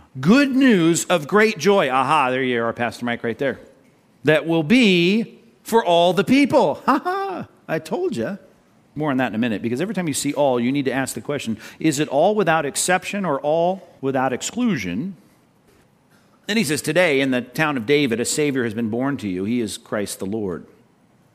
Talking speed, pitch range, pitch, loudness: 205 wpm, 130-200 Hz, 160 Hz, -20 LUFS